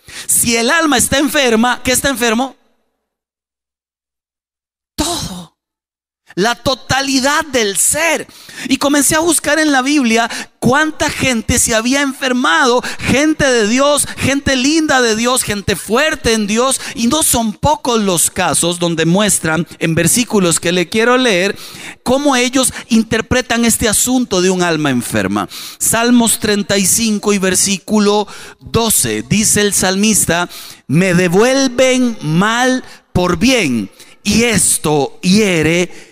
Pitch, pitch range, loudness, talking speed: 225 Hz, 180-255 Hz, -13 LUFS, 125 wpm